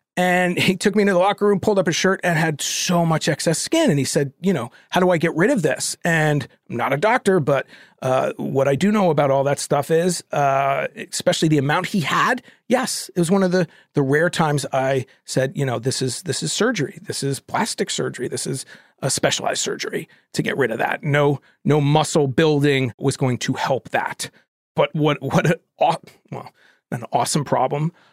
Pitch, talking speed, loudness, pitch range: 160 Hz, 220 wpm, -20 LUFS, 140-180 Hz